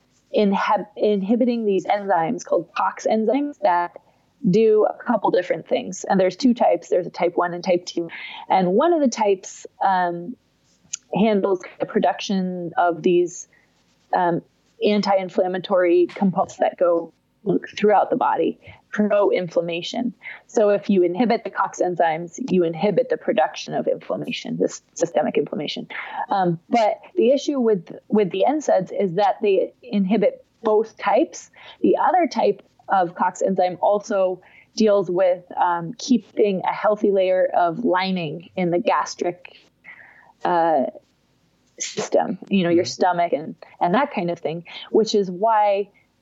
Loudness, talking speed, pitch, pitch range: -21 LUFS, 140 wpm, 200 Hz, 180-235 Hz